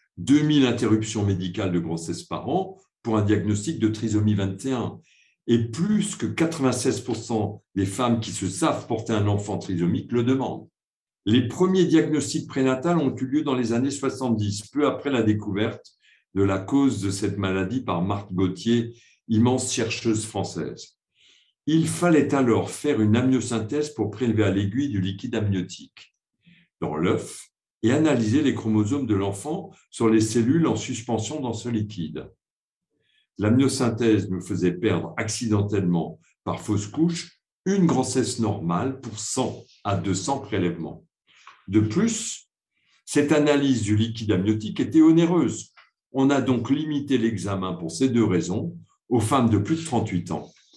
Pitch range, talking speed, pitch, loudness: 105-135 Hz, 150 wpm, 115 Hz, -24 LUFS